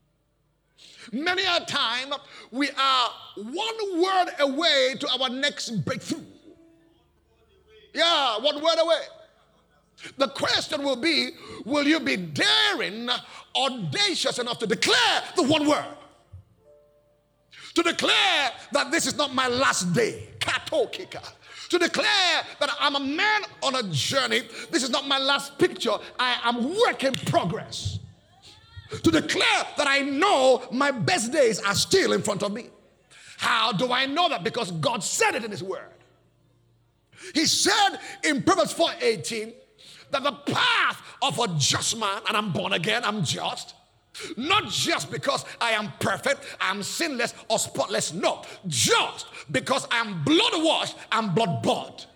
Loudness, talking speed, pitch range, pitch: -24 LUFS, 145 wpm, 235-335 Hz, 280 Hz